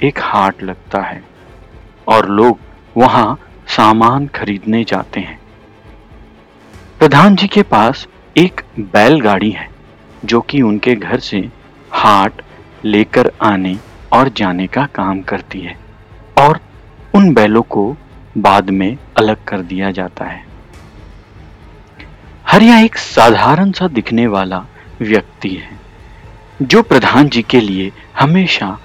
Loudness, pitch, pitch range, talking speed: -12 LUFS, 110 Hz, 95-125 Hz, 90 wpm